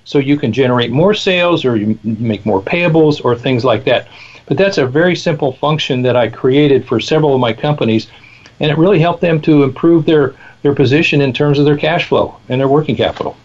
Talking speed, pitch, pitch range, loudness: 220 wpm, 145 Hz, 125-155 Hz, -13 LUFS